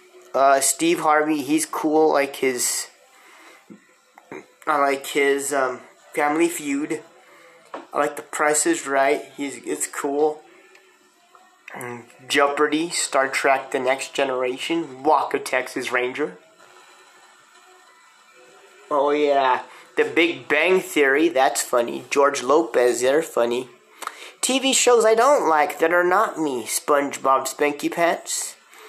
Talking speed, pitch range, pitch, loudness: 115 wpm, 135-180 Hz, 150 Hz, -21 LUFS